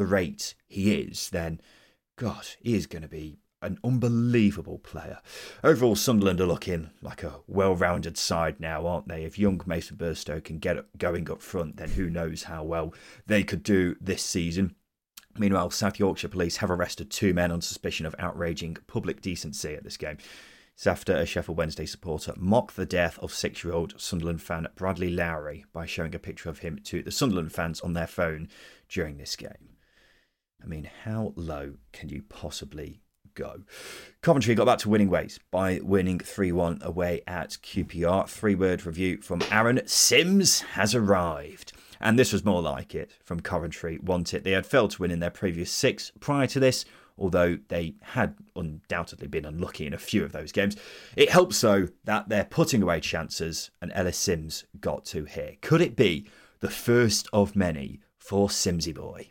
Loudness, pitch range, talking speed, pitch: -27 LUFS, 85-100 Hz, 185 wpm, 90 Hz